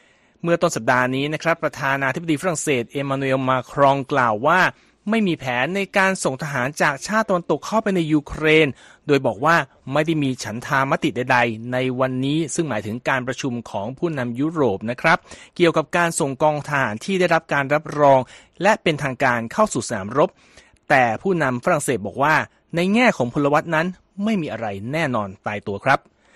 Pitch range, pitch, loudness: 130-170 Hz, 145 Hz, -20 LUFS